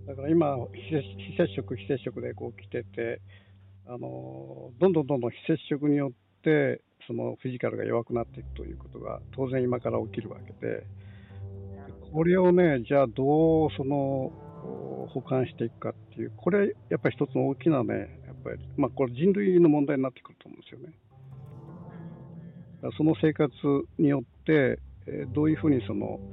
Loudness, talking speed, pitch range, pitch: -28 LUFS, 335 characters per minute, 100-150 Hz, 130 Hz